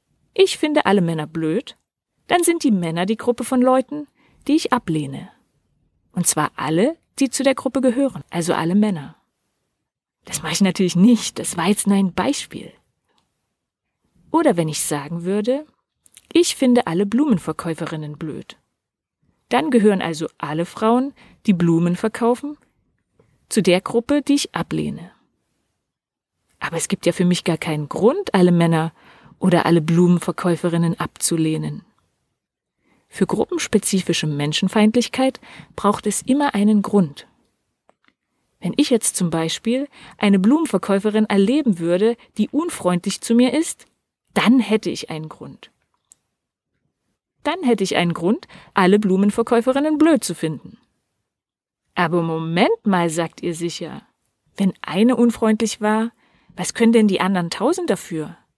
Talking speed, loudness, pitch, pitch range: 135 wpm, -19 LUFS, 200 Hz, 170-245 Hz